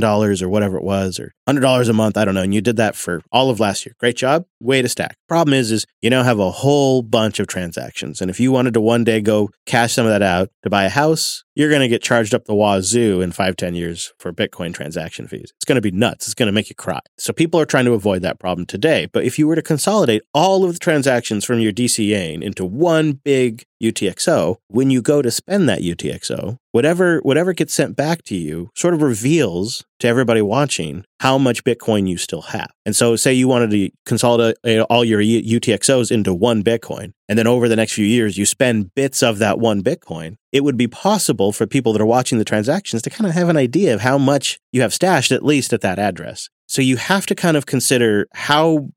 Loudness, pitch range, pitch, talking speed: -17 LUFS, 105-140 Hz, 120 Hz, 245 wpm